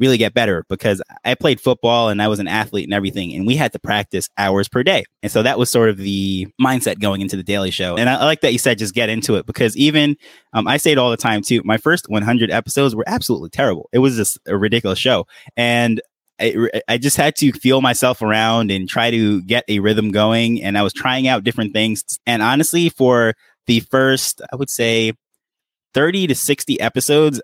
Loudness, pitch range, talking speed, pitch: -16 LUFS, 105-130 Hz, 225 wpm, 115 Hz